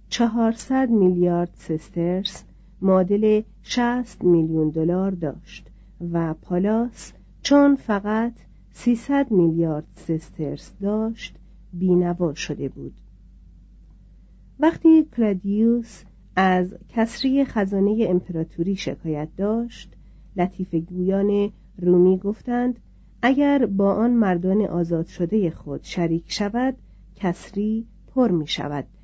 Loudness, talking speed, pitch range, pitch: -22 LUFS, 90 wpm, 175-225 Hz, 195 Hz